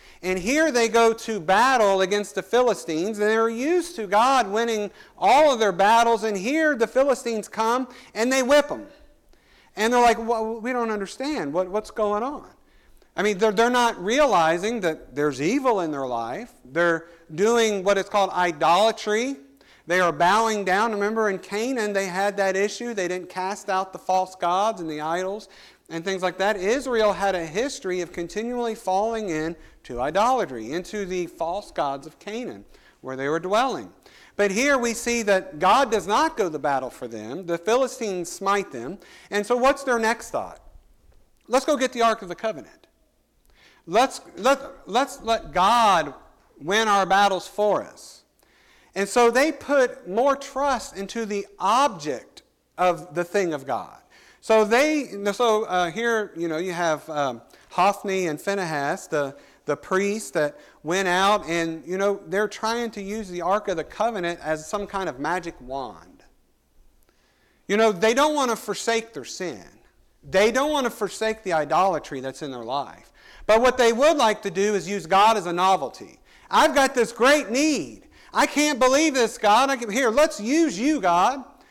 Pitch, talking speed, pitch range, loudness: 210 Hz, 180 wpm, 185-240 Hz, -23 LUFS